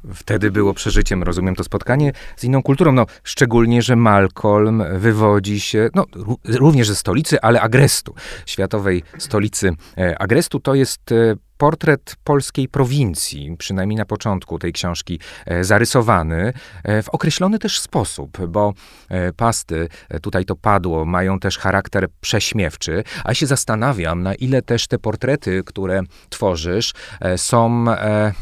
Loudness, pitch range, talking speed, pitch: -18 LUFS, 95-125 Hz, 125 wpm, 105 Hz